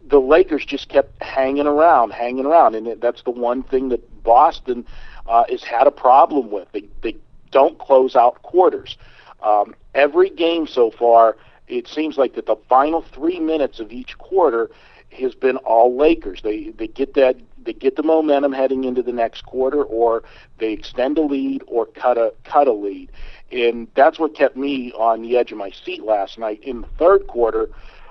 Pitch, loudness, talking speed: 135 Hz, -18 LUFS, 190 wpm